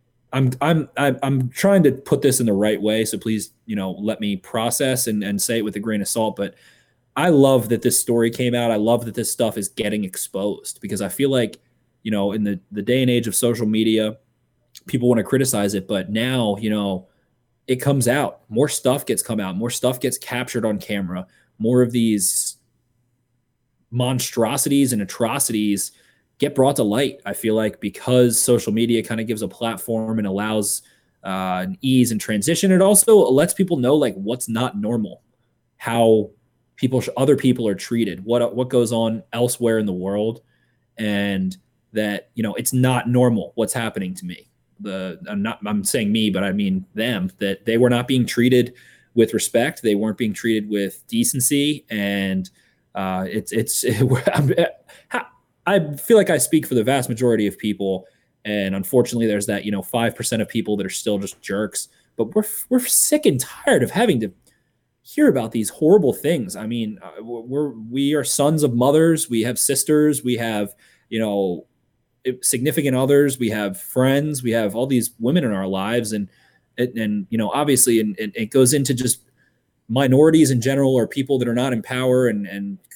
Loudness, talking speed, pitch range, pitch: -20 LUFS, 195 wpm, 105-130 Hz, 115 Hz